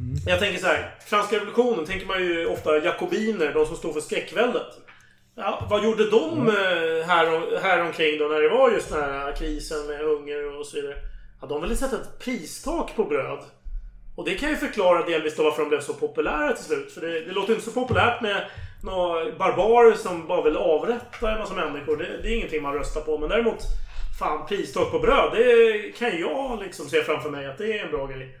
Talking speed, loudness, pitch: 215 wpm, -24 LUFS, 220 Hz